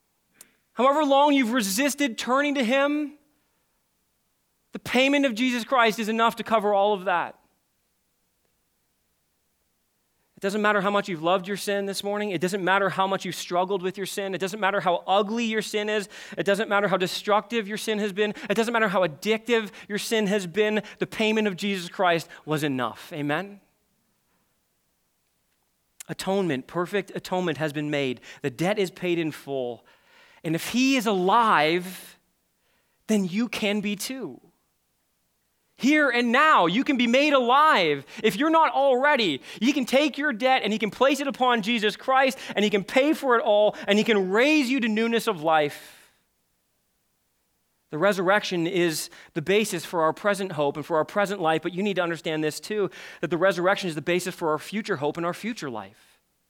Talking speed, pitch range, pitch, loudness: 185 wpm, 175-230 Hz, 200 Hz, -24 LUFS